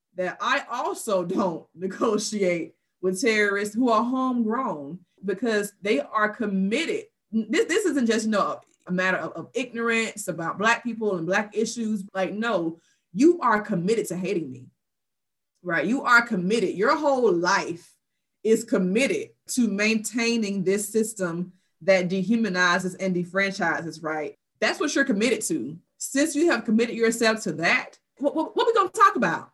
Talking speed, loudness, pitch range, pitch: 155 wpm, -24 LUFS, 185-240 Hz, 215 Hz